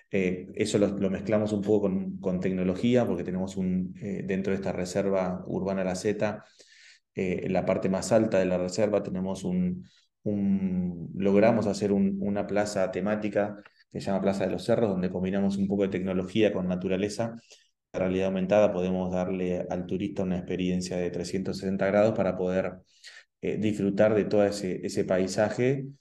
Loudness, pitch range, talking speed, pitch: -28 LUFS, 95-105 Hz, 170 wpm, 95 Hz